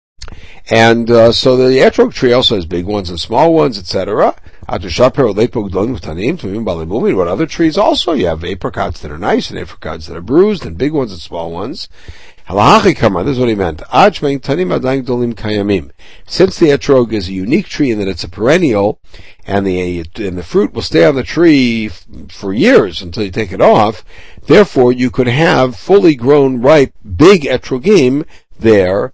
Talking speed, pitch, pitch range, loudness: 165 wpm, 115 Hz, 95-135 Hz, -12 LUFS